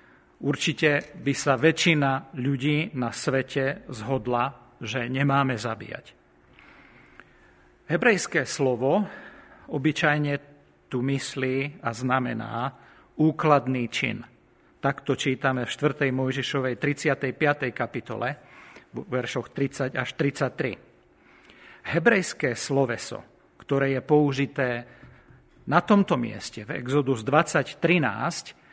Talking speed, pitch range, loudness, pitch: 90 wpm, 125-150 Hz, -25 LUFS, 135 Hz